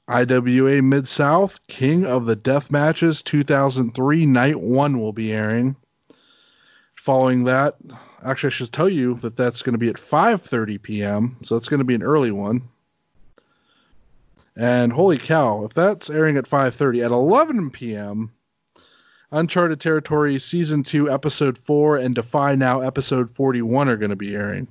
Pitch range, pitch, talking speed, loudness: 120-150 Hz, 135 Hz, 160 wpm, -19 LUFS